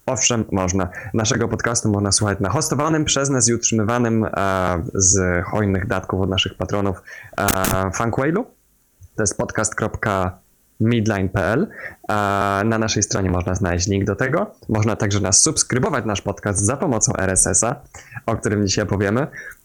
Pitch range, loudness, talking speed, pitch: 95-115 Hz, -19 LUFS, 140 wpm, 105 Hz